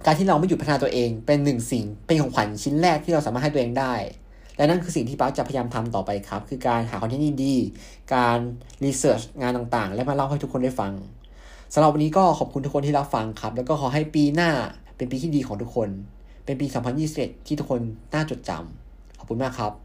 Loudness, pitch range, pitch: -24 LUFS, 115-145 Hz, 130 Hz